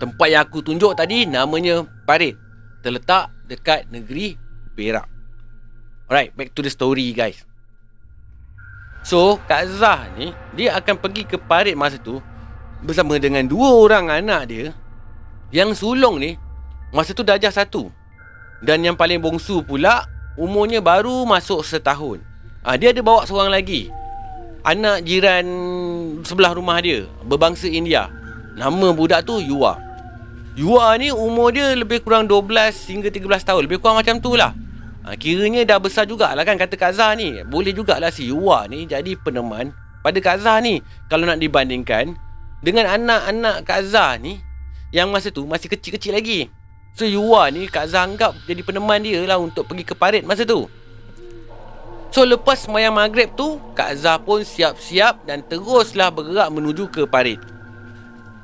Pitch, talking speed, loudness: 170 Hz, 150 wpm, -17 LUFS